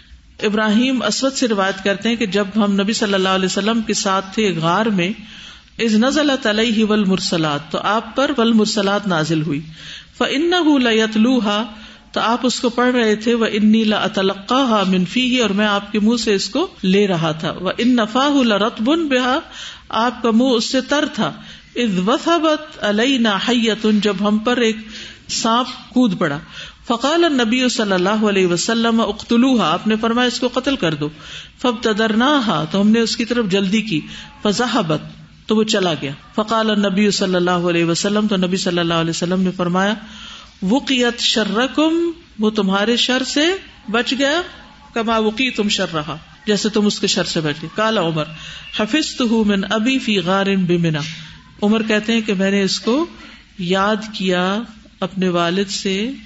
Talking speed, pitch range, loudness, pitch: 170 wpm, 195-240 Hz, -17 LUFS, 215 Hz